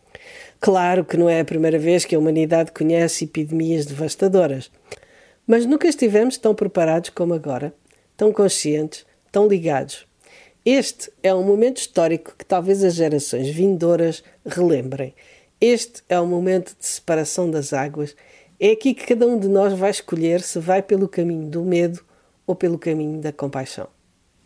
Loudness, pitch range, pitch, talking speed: -19 LUFS, 155-195 Hz, 175 Hz, 155 wpm